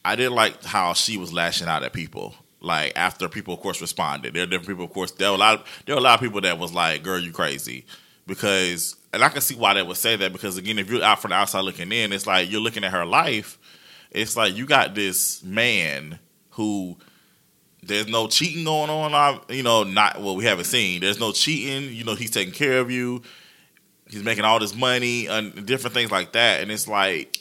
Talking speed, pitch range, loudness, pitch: 240 wpm, 95-120 Hz, -21 LUFS, 105 Hz